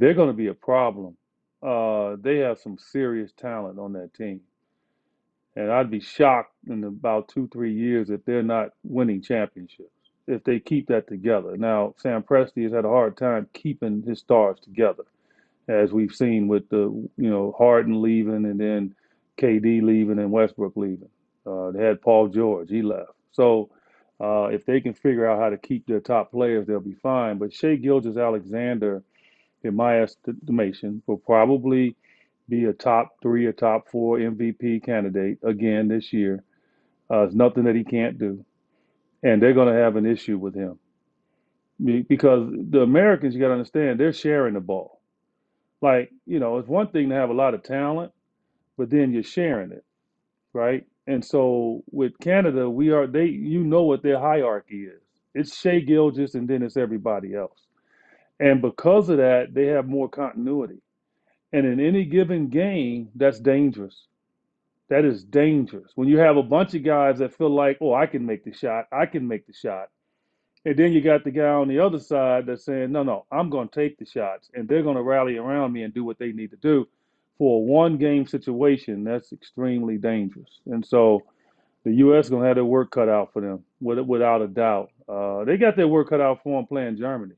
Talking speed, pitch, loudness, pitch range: 190 wpm, 120 Hz, -22 LUFS, 110-140 Hz